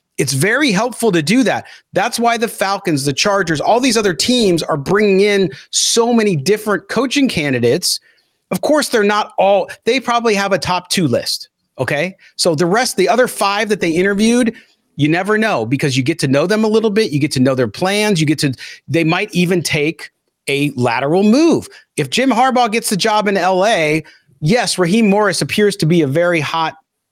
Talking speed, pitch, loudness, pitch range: 200 wpm, 195 Hz, -15 LUFS, 160-220 Hz